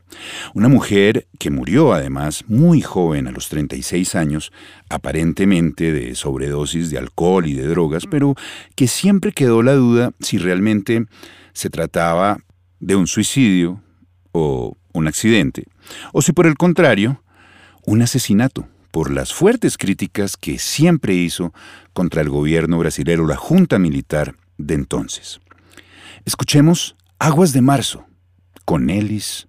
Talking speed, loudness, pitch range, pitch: 130 wpm, -17 LUFS, 80-120 Hz, 90 Hz